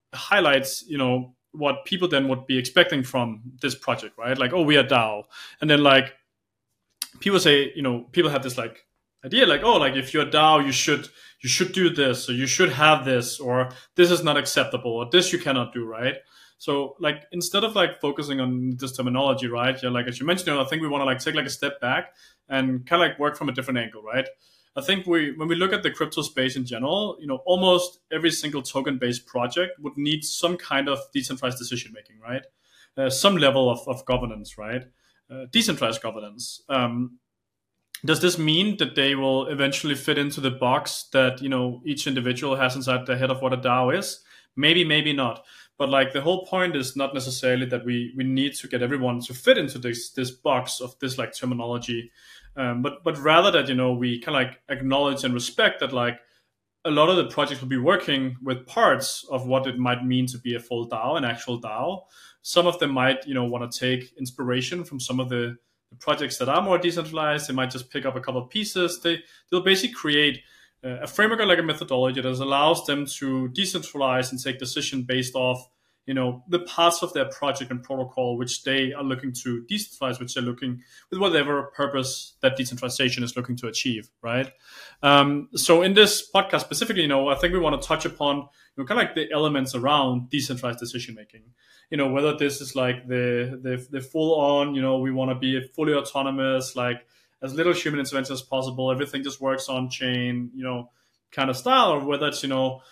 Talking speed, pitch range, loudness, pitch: 215 wpm, 125-150 Hz, -23 LUFS, 135 Hz